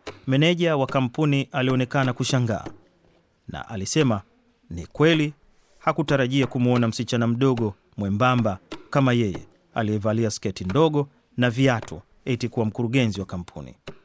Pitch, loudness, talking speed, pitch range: 125 Hz, -23 LUFS, 110 wpm, 110-135 Hz